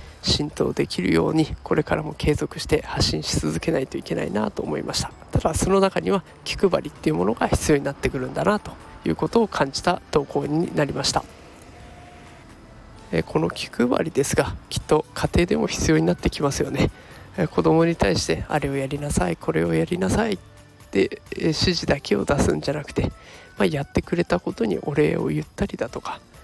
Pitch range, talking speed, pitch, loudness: 130-170 Hz, 375 characters per minute, 150 Hz, -23 LUFS